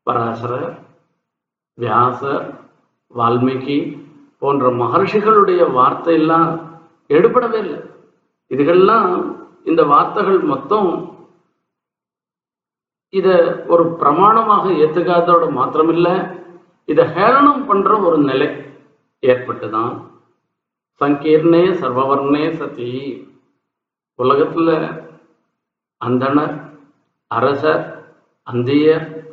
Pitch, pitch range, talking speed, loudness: 160 Hz, 140-175 Hz, 65 wpm, -15 LUFS